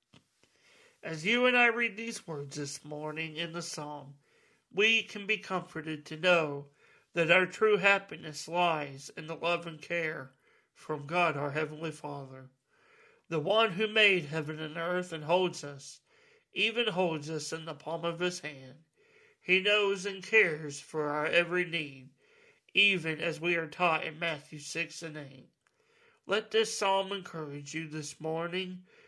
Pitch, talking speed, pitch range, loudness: 170 Hz, 160 wpm, 155-200 Hz, -30 LUFS